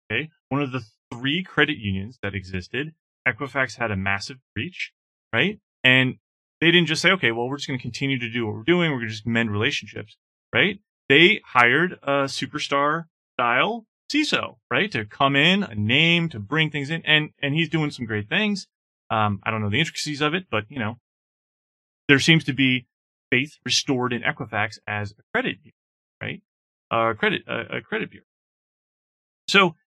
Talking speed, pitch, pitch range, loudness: 185 wpm, 135 Hz, 115-155 Hz, -22 LUFS